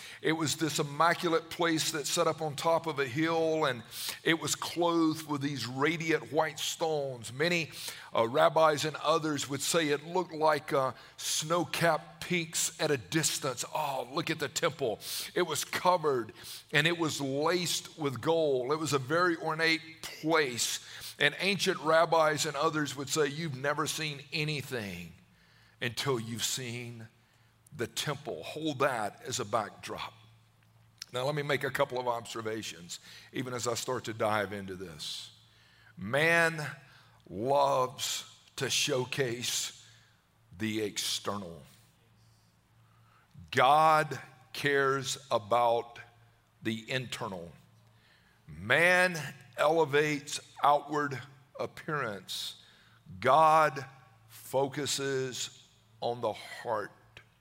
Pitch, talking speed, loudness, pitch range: 140 Hz, 120 wpm, -30 LUFS, 120-160 Hz